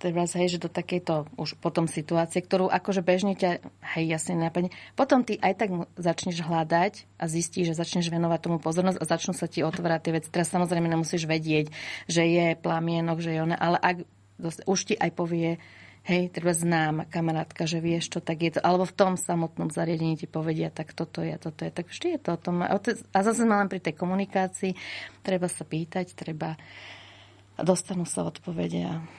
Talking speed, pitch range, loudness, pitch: 190 wpm, 160-180 Hz, -28 LUFS, 170 Hz